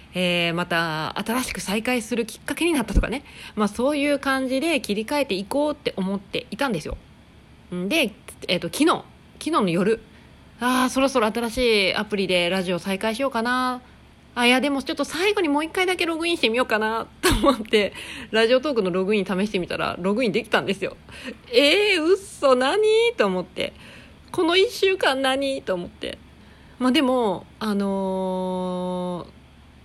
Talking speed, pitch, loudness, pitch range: 345 characters per minute, 230 Hz, -22 LUFS, 190-280 Hz